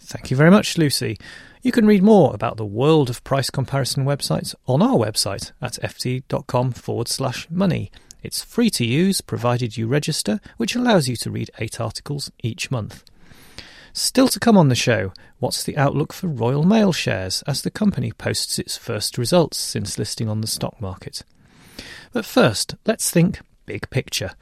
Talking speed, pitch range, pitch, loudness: 175 wpm, 115-175 Hz, 135 Hz, -20 LUFS